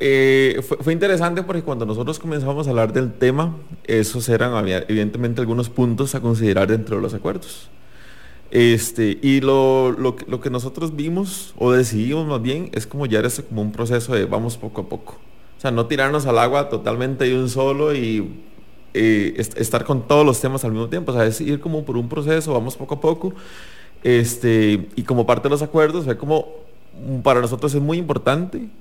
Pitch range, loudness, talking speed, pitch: 115-150 Hz, -19 LUFS, 195 wpm, 130 Hz